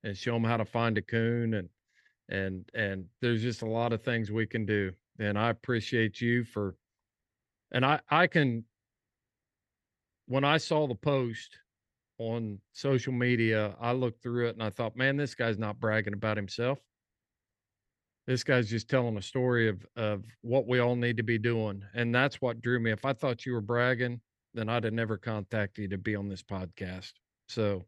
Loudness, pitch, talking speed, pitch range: -31 LUFS, 115 Hz, 190 wpm, 105-120 Hz